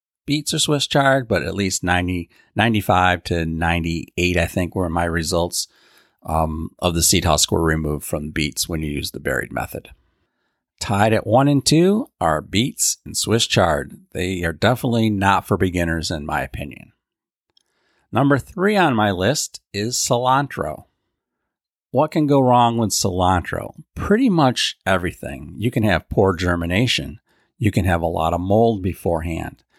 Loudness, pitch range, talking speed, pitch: -19 LUFS, 85-120 Hz, 160 wpm, 95 Hz